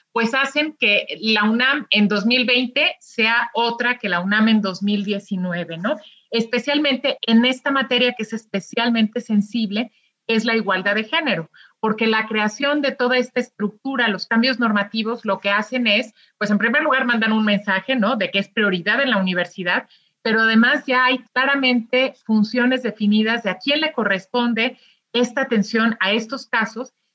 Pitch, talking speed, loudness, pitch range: 230 Hz, 165 wpm, -19 LUFS, 210-255 Hz